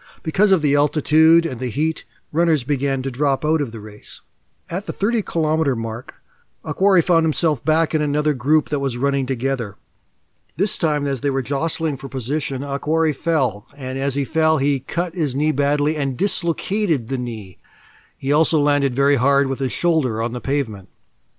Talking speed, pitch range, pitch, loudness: 180 wpm, 135-160 Hz, 145 Hz, -20 LUFS